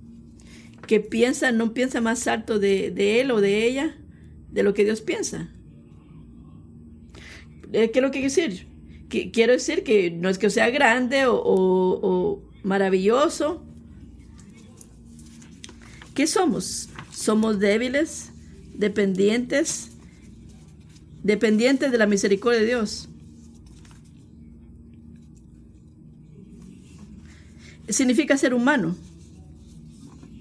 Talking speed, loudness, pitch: 95 wpm, -22 LUFS, 200 Hz